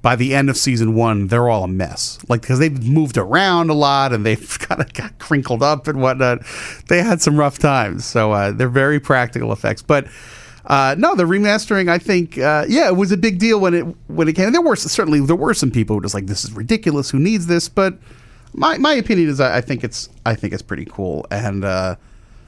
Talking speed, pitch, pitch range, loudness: 240 wpm, 135 Hz, 115-170 Hz, -16 LUFS